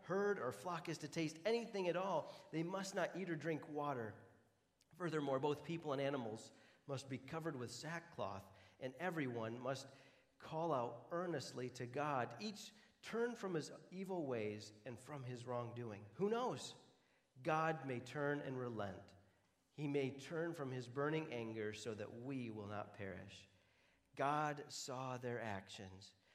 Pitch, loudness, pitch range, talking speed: 135 Hz, -45 LUFS, 115-160 Hz, 155 wpm